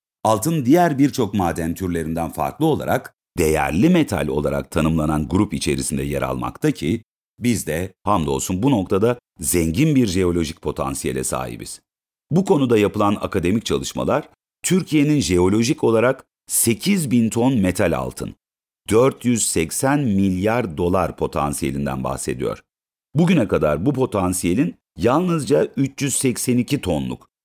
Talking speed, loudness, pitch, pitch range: 110 wpm, -20 LUFS, 95 Hz, 80-125 Hz